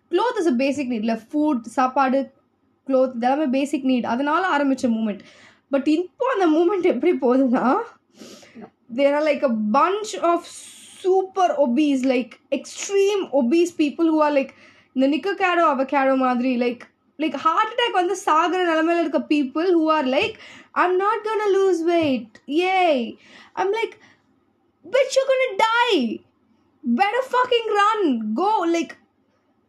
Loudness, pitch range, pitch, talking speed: -21 LUFS, 270-375 Hz, 310 Hz, 135 wpm